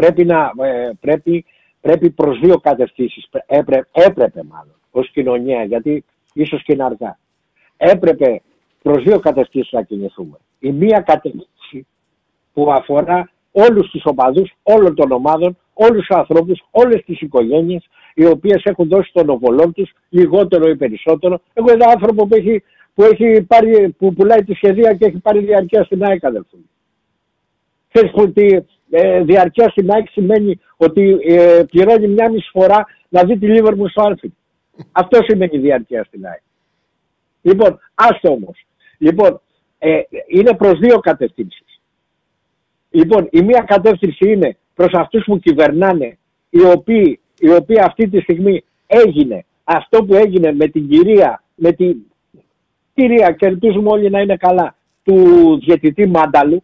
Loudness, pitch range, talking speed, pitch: -12 LUFS, 160-215 Hz, 145 wpm, 185 Hz